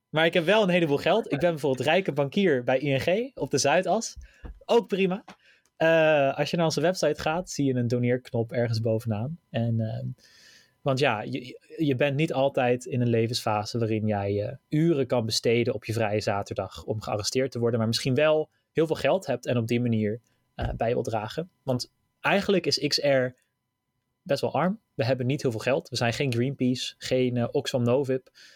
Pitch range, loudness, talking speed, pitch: 120-155 Hz, -26 LUFS, 200 wpm, 130 Hz